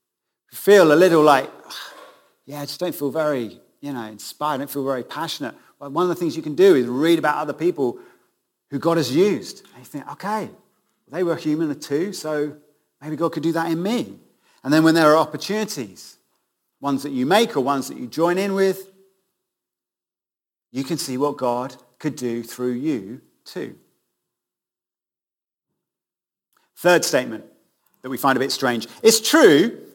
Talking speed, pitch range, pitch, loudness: 180 wpm, 135-180 Hz, 150 Hz, -20 LUFS